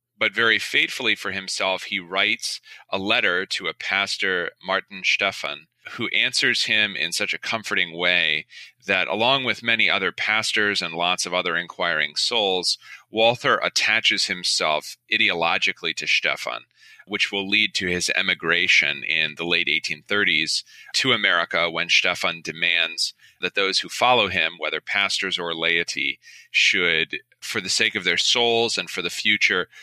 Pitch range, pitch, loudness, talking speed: 90-115 Hz, 105 Hz, -21 LUFS, 150 wpm